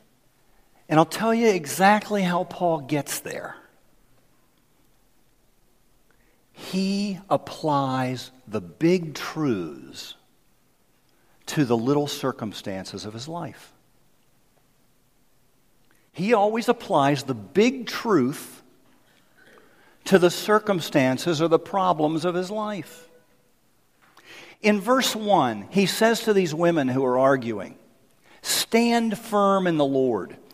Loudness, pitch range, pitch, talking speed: -23 LUFS, 140-205 Hz, 170 Hz, 100 wpm